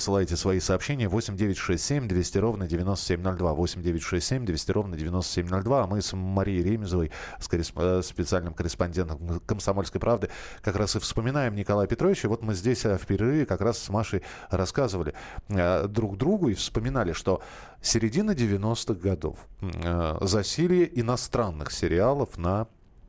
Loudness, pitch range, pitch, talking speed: -27 LUFS, 90-115 Hz, 100 Hz, 125 wpm